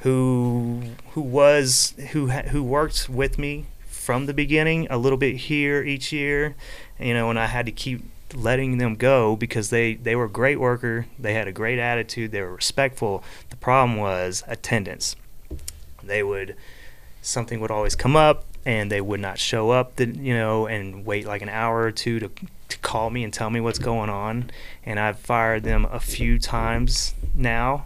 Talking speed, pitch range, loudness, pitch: 190 wpm, 110-130 Hz, -23 LUFS, 120 Hz